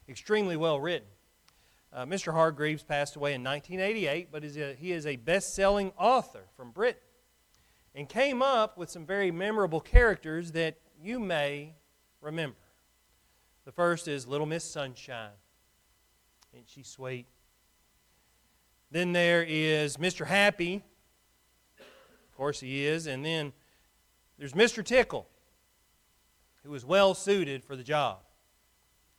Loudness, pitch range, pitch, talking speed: -29 LUFS, 140-185 Hz, 155 Hz, 130 wpm